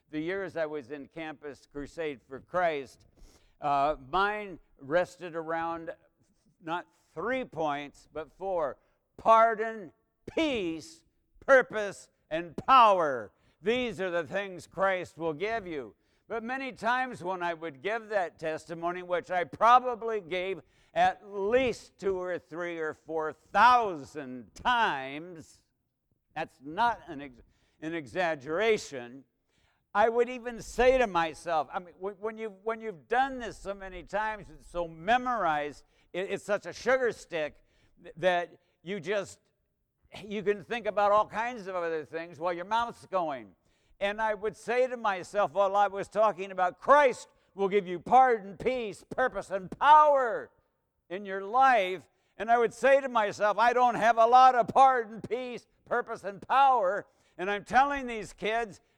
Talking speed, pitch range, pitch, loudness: 150 wpm, 165-225 Hz, 195 Hz, -28 LUFS